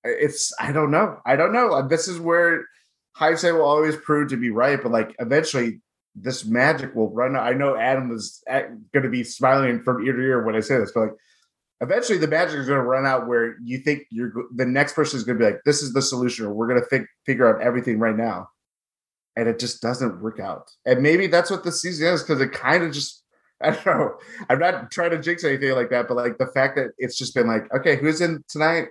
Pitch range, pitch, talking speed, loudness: 120-155 Hz, 135 Hz, 245 wpm, -21 LUFS